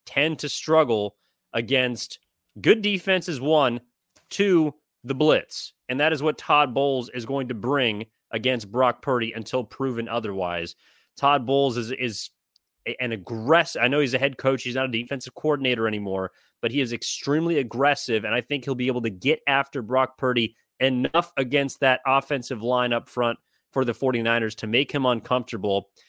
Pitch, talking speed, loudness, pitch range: 130 Hz, 170 wpm, -24 LUFS, 120-140 Hz